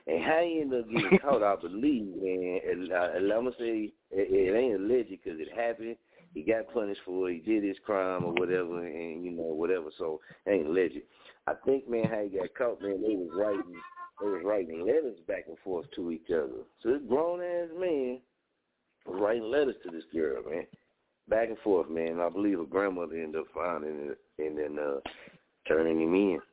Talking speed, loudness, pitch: 205 wpm, -31 LUFS, 115 Hz